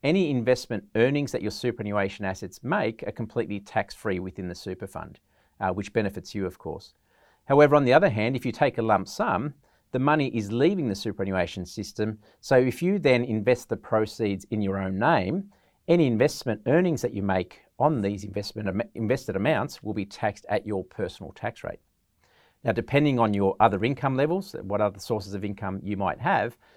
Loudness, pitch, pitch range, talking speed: -26 LUFS, 110 Hz, 100-125 Hz, 190 wpm